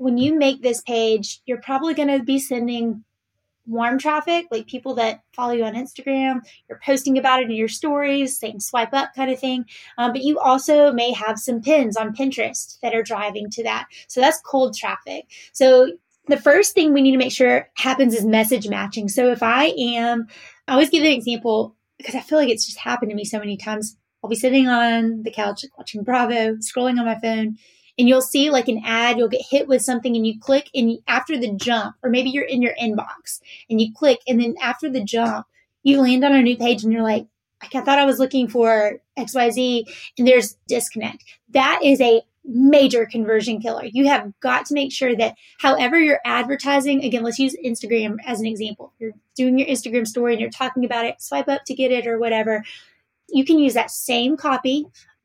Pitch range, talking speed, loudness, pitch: 230-270 Hz, 210 wpm, -19 LUFS, 245 Hz